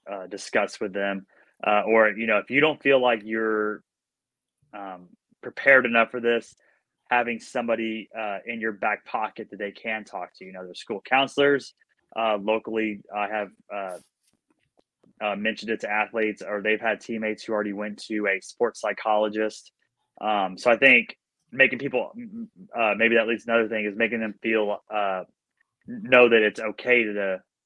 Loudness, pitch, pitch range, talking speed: -24 LUFS, 110 Hz, 105-120 Hz, 180 wpm